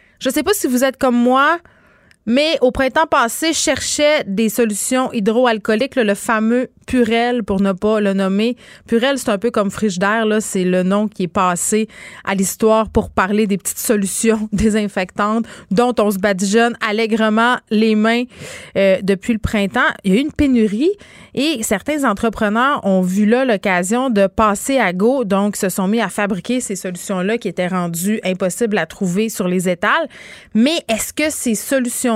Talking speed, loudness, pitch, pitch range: 180 wpm, -16 LUFS, 220 Hz, 200-245 Hz